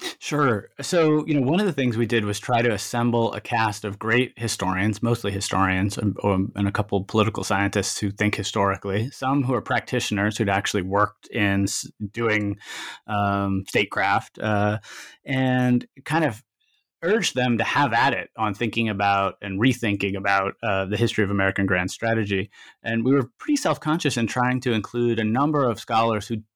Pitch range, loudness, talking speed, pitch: 100-125 Hz, -23 LUFS, 180 wpm, 110 Hz